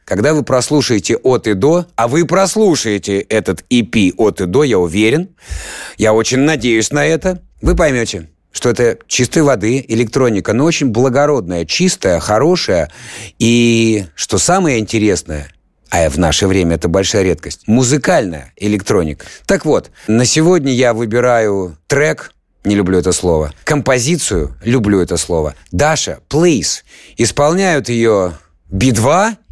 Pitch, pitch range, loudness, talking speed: 115 Hz, 95-140 Hz, -13 LUFS, 135 wpm